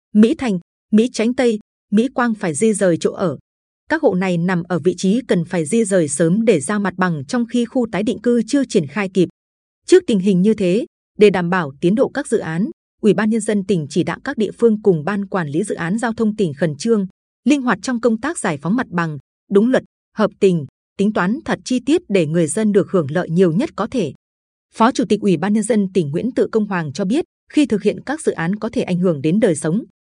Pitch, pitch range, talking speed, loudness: 205 Hz, 180-230 Hz, 255 wpm, -18 LUFS